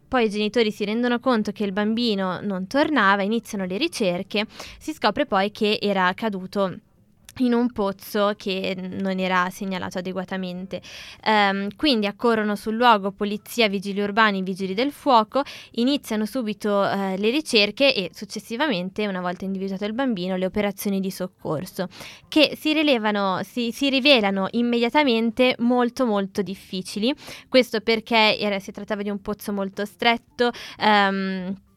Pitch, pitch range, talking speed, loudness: 210 Hz, 195-235 Hz, 145 wpm, -22 LUFS